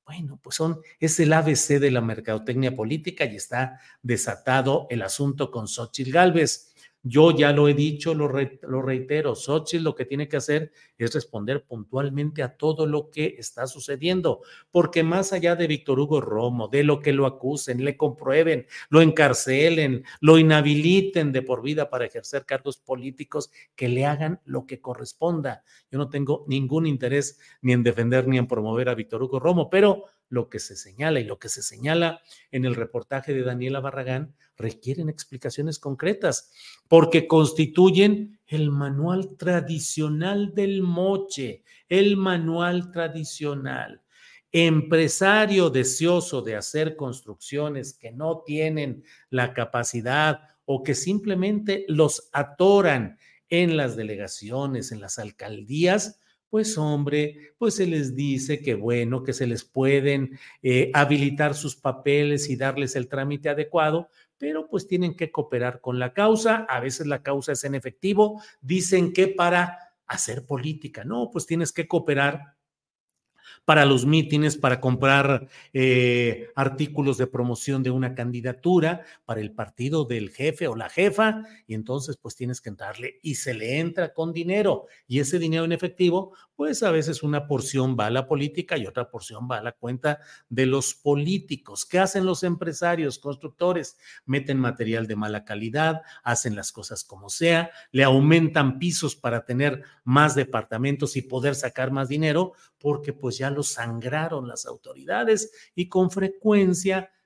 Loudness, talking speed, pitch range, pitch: -24 LUFS, 155 wpm, 130-165 Hz, 145 Hz